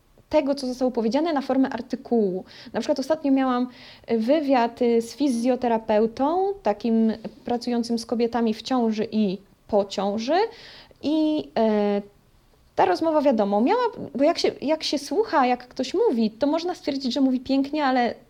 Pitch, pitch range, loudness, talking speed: 255 Hz, 225-295 Hz, -23 LUFS, 150 wpm